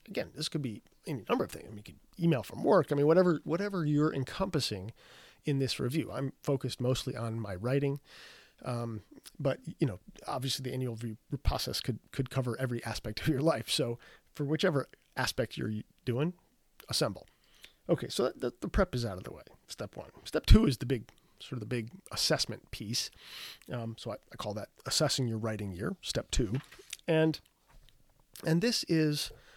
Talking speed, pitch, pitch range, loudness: 190 wpm, 130 Hz, 115-155 Hz, -33 LUFS